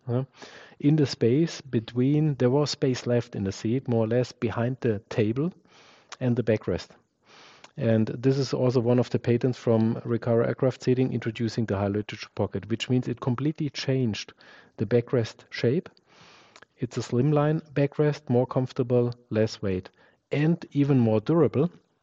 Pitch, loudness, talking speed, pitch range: 125 Hz, -26 LUFS, 155 wpm, 115-140 Hz